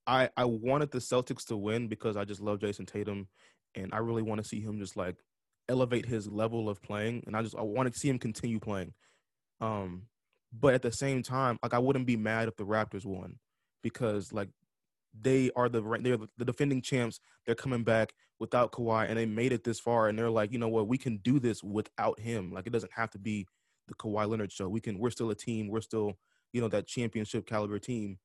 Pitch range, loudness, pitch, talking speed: 105-120 Hz, -33 LUFS, 115 Hz, 230 wpm